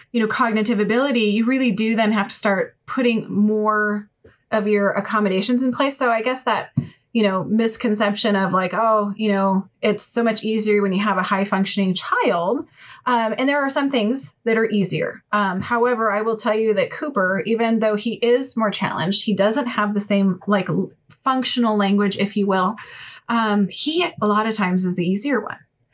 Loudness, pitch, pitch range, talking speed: -20 LUFS, 215 Hz, 200-230 Hz, 195 wpm